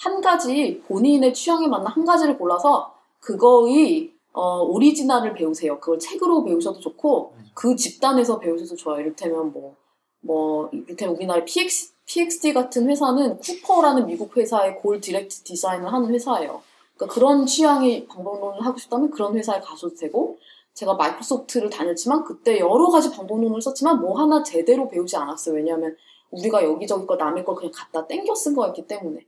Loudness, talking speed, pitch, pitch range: -21 LUFS, 400 characters per minute, 245 Hz, 180-295 Hz